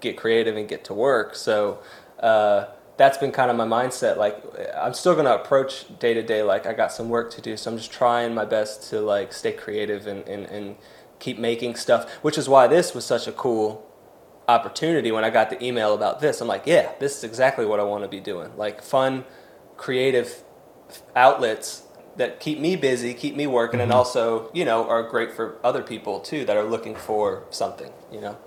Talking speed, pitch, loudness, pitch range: 215 wpm, 120 Hz, -23 LUFS, 110-140 Hz